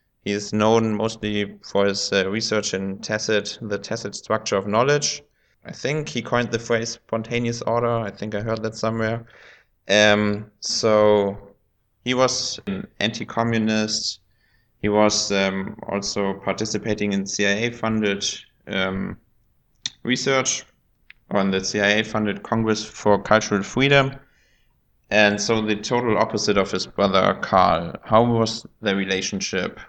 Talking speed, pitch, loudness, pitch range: 135 wpm, 110 Hz, -22 LUFS, 100-115 Hz